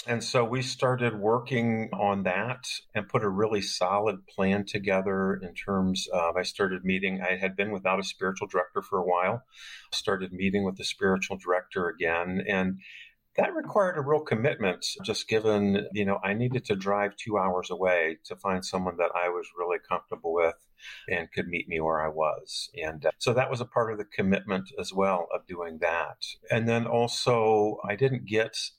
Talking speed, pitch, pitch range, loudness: 190 wpm, 100 Hz, 95-115 Hz, -28 LUFS